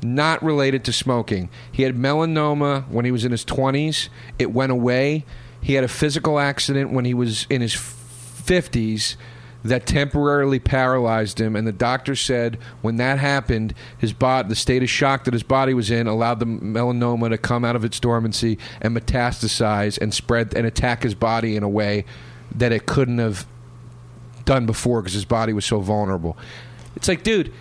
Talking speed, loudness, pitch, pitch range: 185 wpm, -21 LUFS, 120 Hz, 115-130 Hz